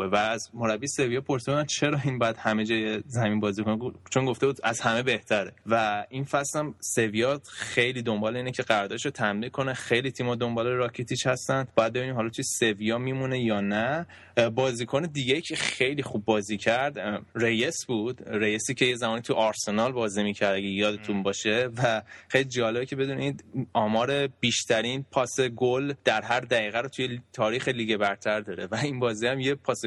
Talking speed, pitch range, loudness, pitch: 175 wpm, 110-130 Hz, -27 LUFS, 120 Hz